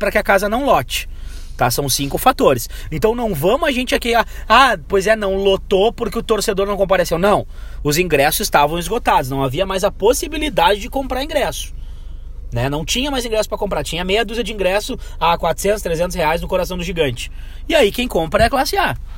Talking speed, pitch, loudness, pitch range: 215 wpm, 195 Hz, -17 LUFS, 155-225 Hz